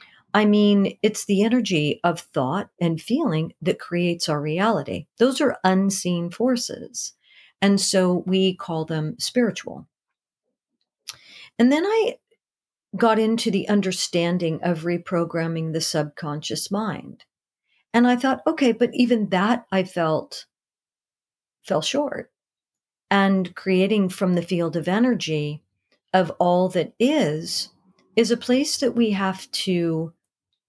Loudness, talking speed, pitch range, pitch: -22 LUFS, 125 wpm, 170-230 Hz, 190 Hz